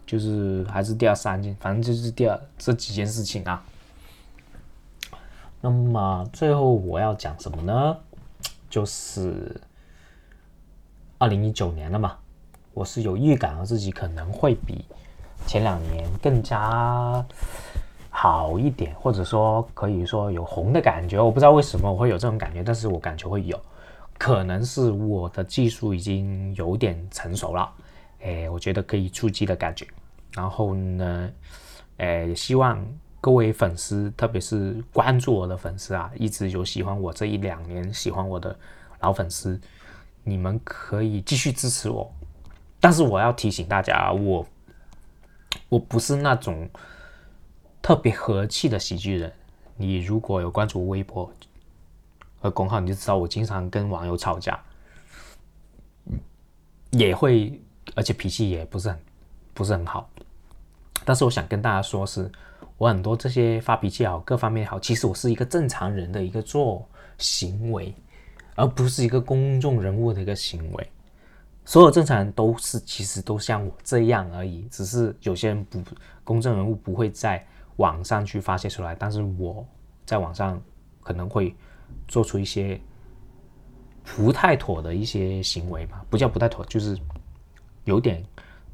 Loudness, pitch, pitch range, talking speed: -24 LUFS, 100 Hz, 90-115 Hz, 235 characters per minute